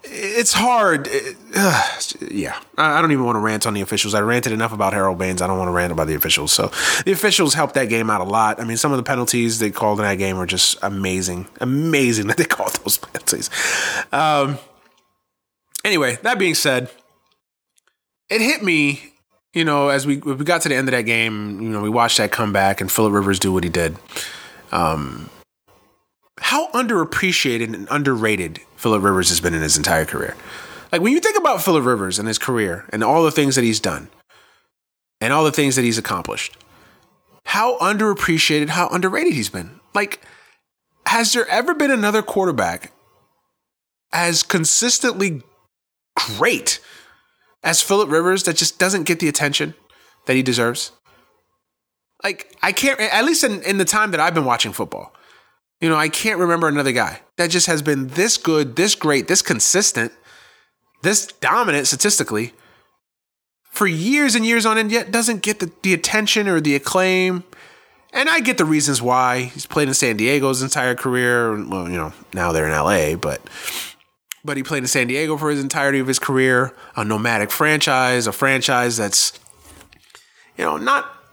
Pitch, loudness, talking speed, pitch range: 140 Hz, -18 LUFS, 180 wpm, 110-180 Hz